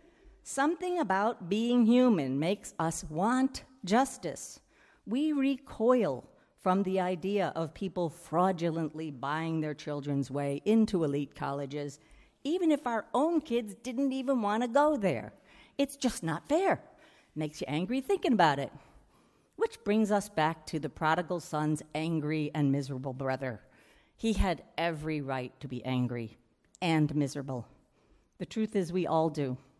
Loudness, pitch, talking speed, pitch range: -31 LUFS, 180 Hz, 145 wpm, 150-245 Hz